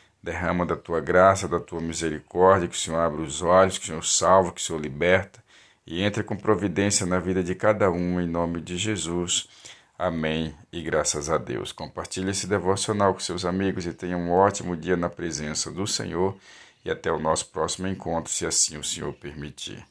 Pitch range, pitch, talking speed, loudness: 85-95 Hz, 90 Hz, 195 wpm, -25 LUFS